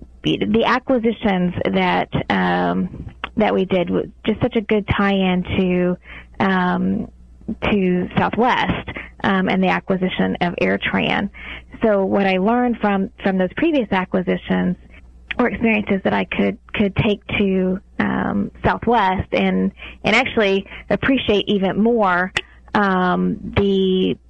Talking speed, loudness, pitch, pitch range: 125 wpm, -19 LUFS, 195 Hz, 180-210 Hz